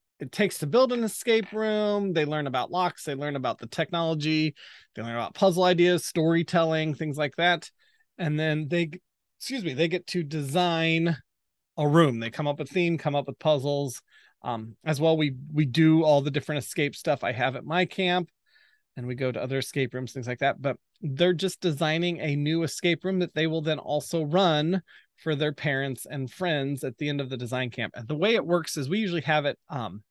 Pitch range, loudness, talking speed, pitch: 140-175 Hz, -27 LUFS, 215 wpm, 155 Hz